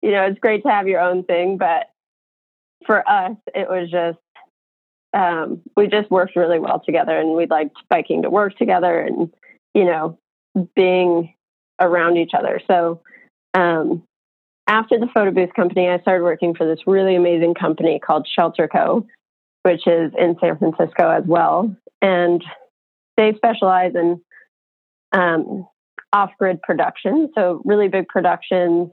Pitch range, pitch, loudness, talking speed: 170-195 Hz, 180 Hz, -18 LUFS, 150 wpm